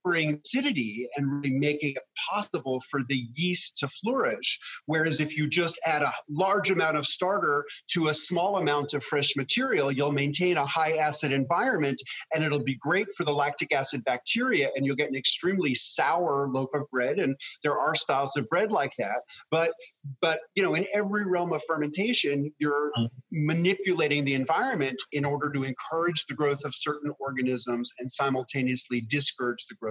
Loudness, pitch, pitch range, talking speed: -26 LUFS, 145 Hz, 135-165 Hz, 175 wpm